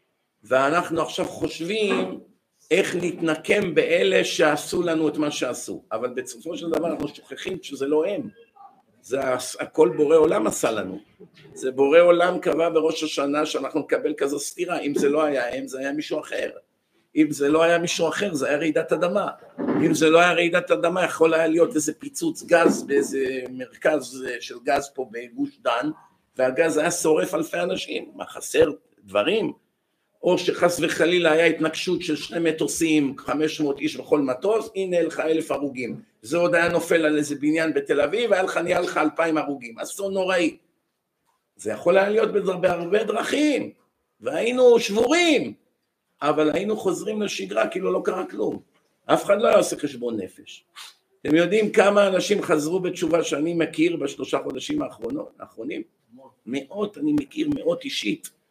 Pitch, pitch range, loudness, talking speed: 170 Hz, 155-215 Hz, -22 LUFS, 160 wpm